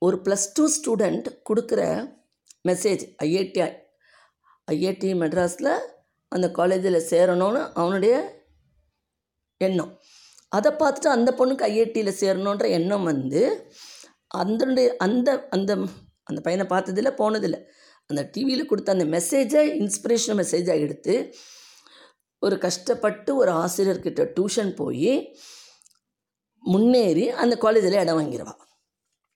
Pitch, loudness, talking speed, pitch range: 195 Hz, -23 LUFS, 100 wpm, 170-235 Hz